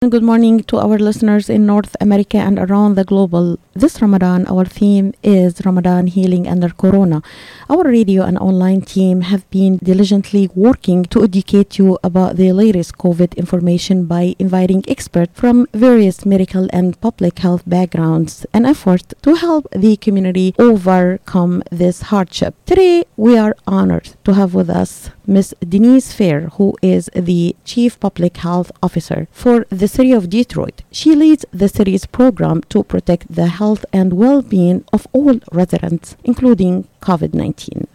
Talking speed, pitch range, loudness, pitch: 155 wpm, 180-215 Hz, -13 LUFS, 195 Hz